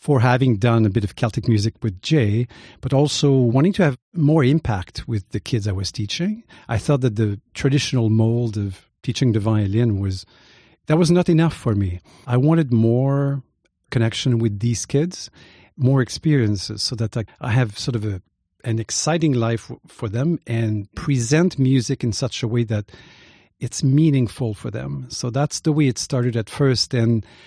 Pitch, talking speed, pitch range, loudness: 120 Hz, 180 wpm, 110-140 Hz, -20 LUFS